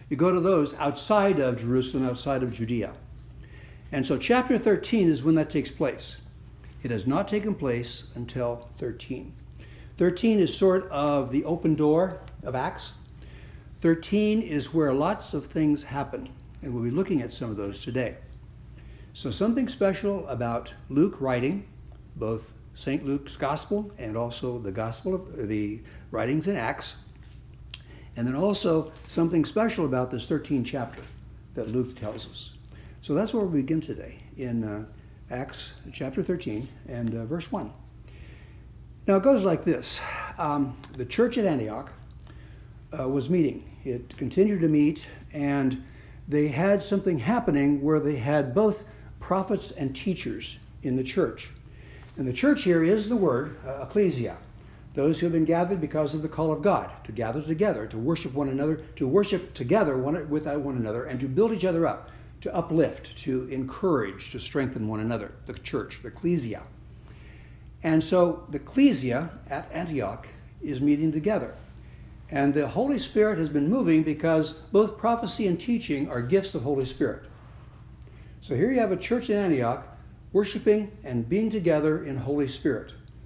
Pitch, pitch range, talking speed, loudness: 145 Hz, 125-185 Hz, 160 wpm, -27 LUFS